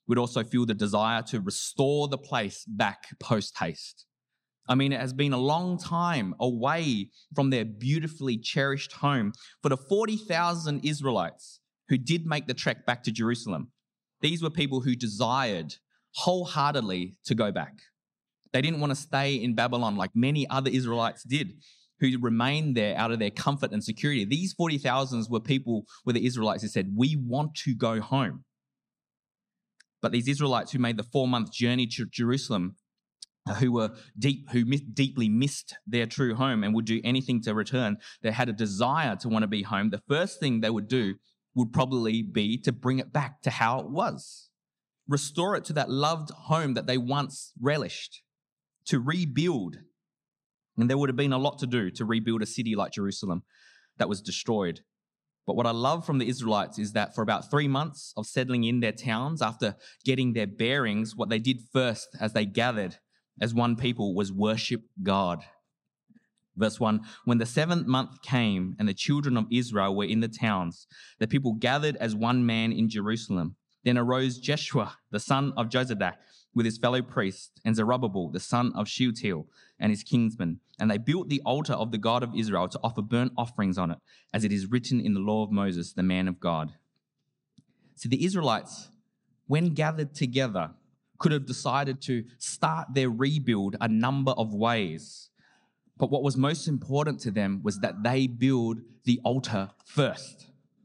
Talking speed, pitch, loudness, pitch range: 180 wpm, 125 Hz, -28 LUFS, 110-140 Hz